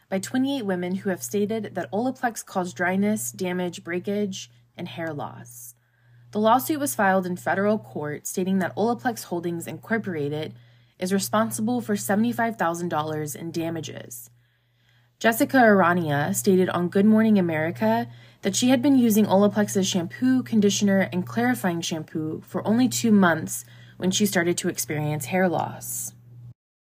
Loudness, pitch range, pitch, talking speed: -24 LUFS, 155-210 Hz, 185 Hz, 140 wpm